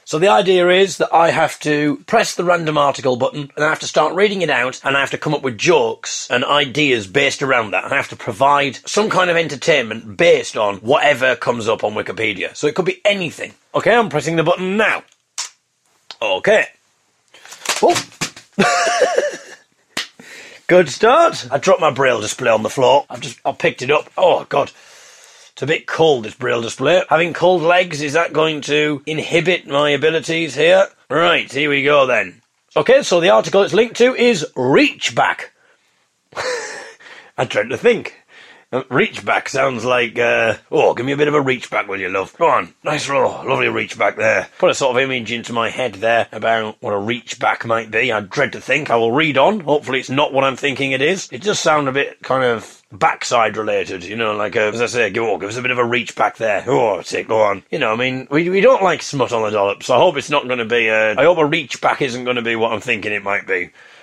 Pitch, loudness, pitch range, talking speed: 145 Hz, -16 LUFS, 125-185 Hz, 225 wpm